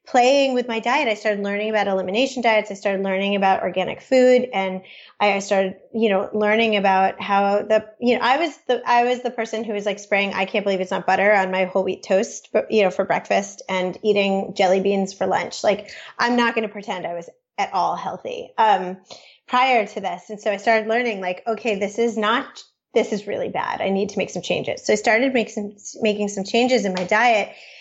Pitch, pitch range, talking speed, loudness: 210 Hz, 195-230 Hz, 230 wpm, -21 LUFS